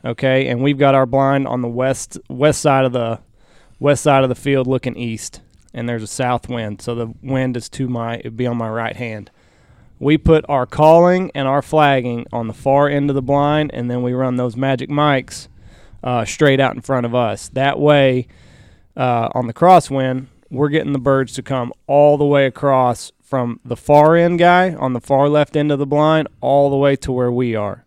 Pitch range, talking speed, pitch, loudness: 120-145 Hz, 215 wpm, 130 Hz, -16 LUFS